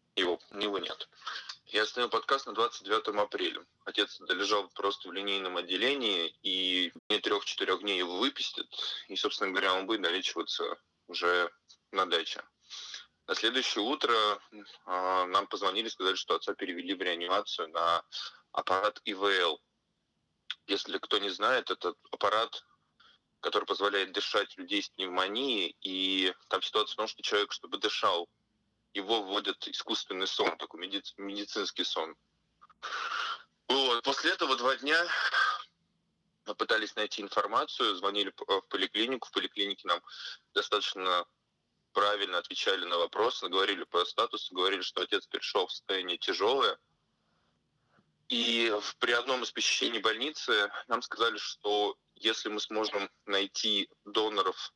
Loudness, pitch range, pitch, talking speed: -31 LUFS, 95-110 Hz, 100 Hz, 125 wpm